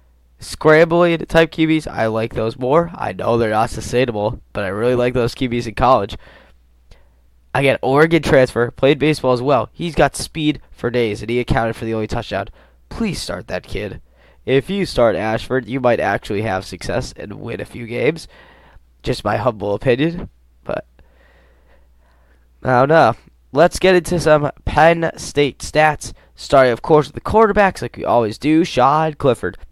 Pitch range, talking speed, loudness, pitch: 100-155 Hz, 170 wpm, -17 LUFS, 120 Hz